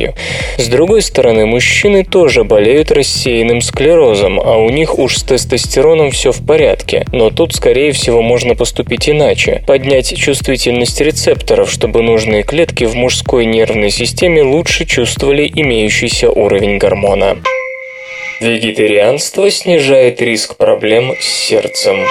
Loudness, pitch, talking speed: -10 LUFS, 155 Hz, 120 wpm